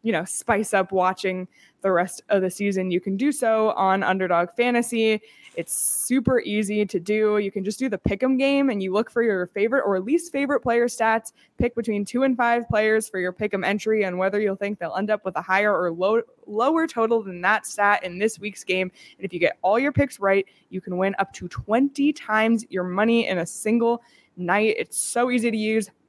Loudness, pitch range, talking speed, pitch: -23 LUFS, 190-235 Hz, 230 wpm, 210 Hz